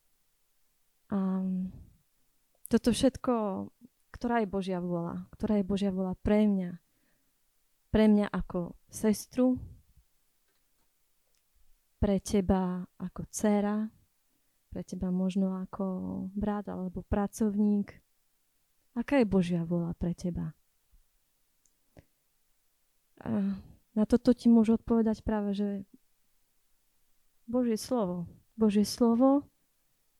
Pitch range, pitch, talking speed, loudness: 185-225 Hz, 205 Hz, 90 wpm, -30 LUFS